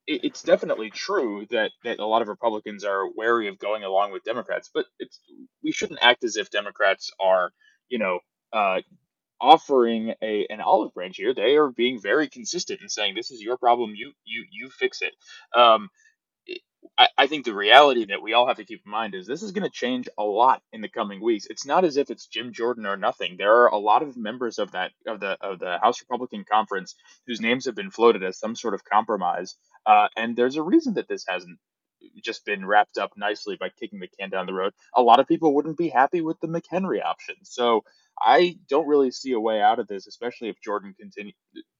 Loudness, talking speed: -23 LUFS, 220 wpm